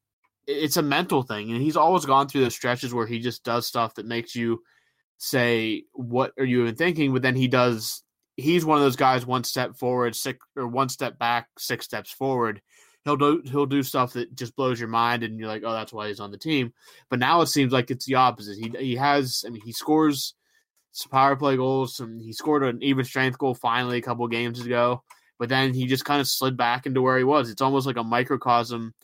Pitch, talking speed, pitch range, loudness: 130 Hz, 235 wpm, 120-135 Hz, -24 LUFS